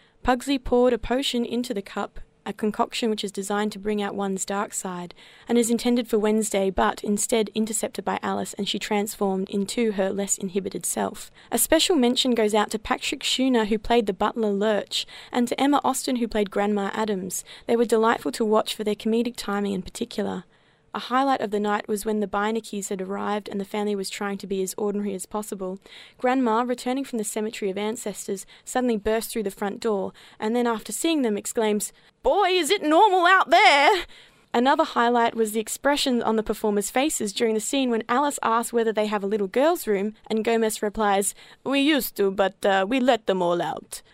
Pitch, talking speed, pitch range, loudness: 220 Hz, 205 wpm, 205-240 Hz, -24 LUFS